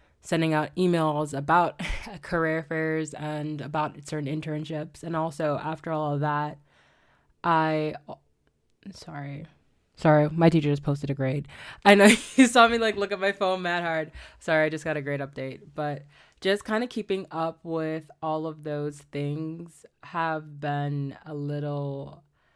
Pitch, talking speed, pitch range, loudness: 155 Hz, 160 wpm, 145-165 Hz, -26 LUFS